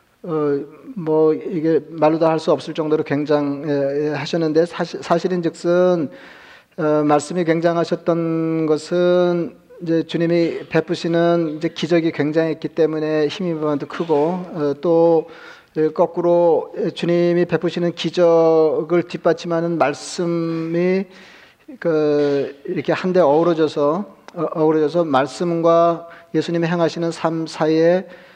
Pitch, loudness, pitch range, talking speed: 165 Hz, -19 LUFS, 155-175 Hz, 250 characters per minute